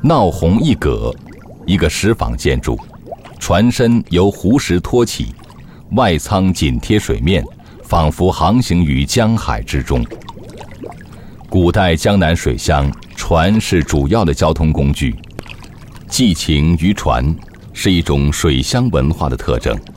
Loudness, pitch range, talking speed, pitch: -15 LUFS, 75-100 Hz, 185 characters per minute, 85 Hz